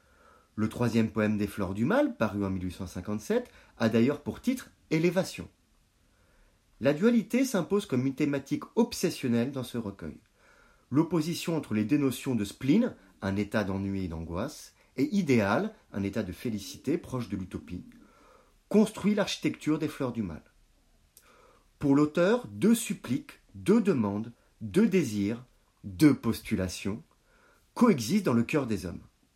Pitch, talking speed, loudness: 125 Hz, 135 wpm, -29 LUFS